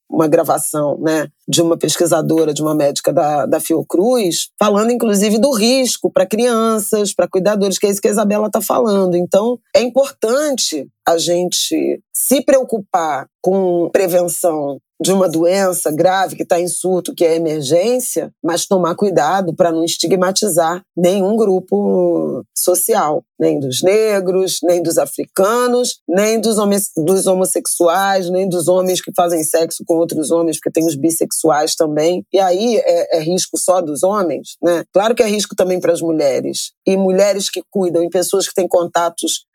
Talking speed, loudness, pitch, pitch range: 165 wpm, -15 LUFS, 180 Hz, 165-205 Hz